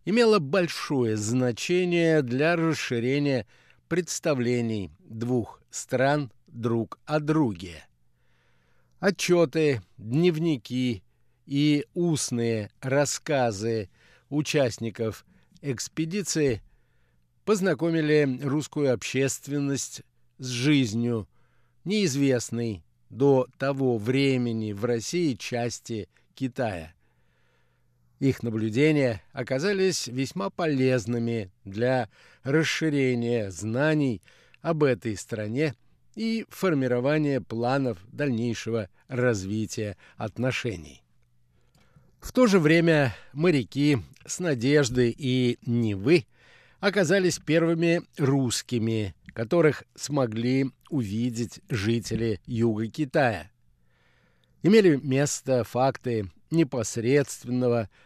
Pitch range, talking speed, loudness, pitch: 115-150 Hz, 70 wpm, -26 LUFS, 125 Hz